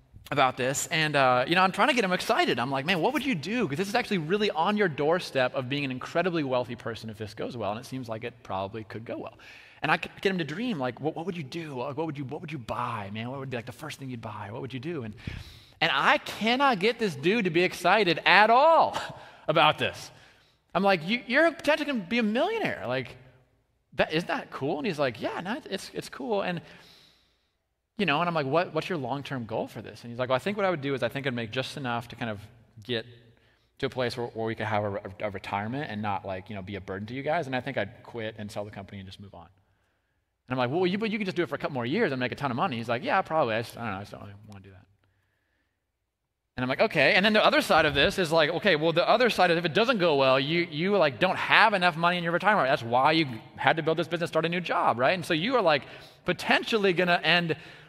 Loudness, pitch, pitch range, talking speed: -26 LUFS, 135 Hz, 115-175 Hz, 290 wpm